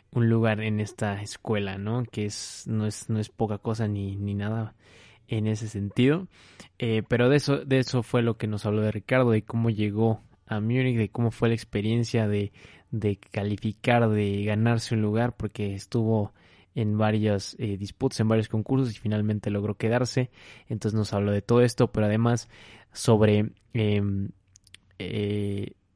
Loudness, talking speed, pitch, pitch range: -27 LUFS, 170 wpm, 110 Hz, 105-115 Hz